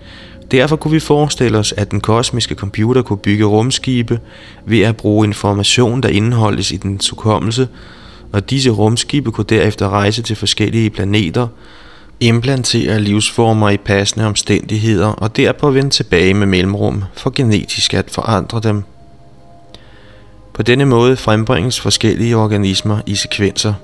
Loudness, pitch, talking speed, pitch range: -14 LUFS, 110 Hz, 135 wpm, 100-120 Hz